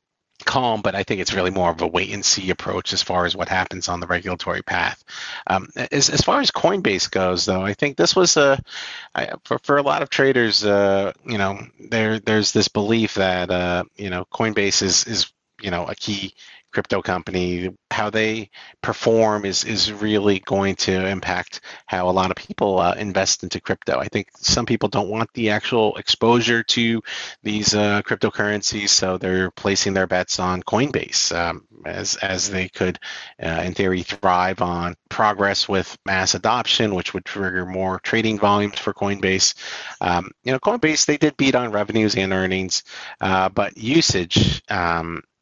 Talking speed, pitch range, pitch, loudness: 180 wpm, 90-110 Hz, 100 Hz, -20 LUFS